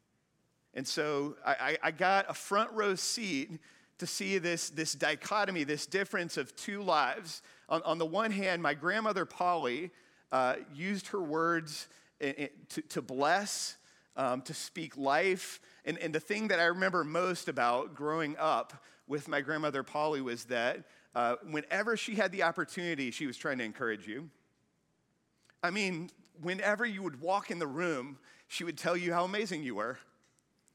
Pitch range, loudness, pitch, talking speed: 150-195 Hz, -34 LUFS, 170 Hz, 170 wpm